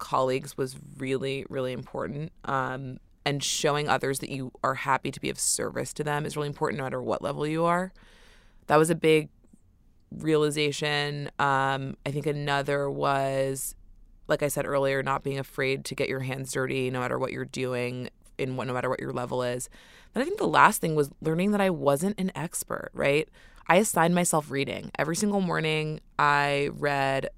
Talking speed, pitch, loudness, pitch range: 190 wpm, 140 Hz, -27 LUFS, 130-155 Hz